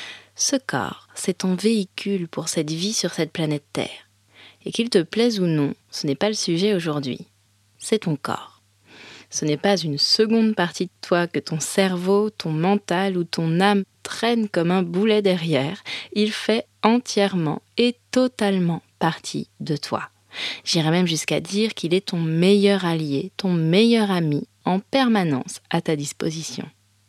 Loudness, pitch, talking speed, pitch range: -22 LUFS, 180 Hz, 160 wpm, 155-205 Hz